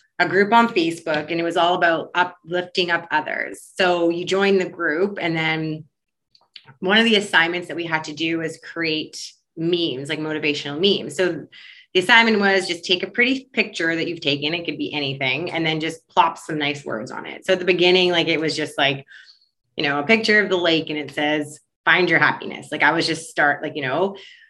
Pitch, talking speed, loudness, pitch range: 170 Hz, 220 wpm, -20 LUFS, 155-185 Hz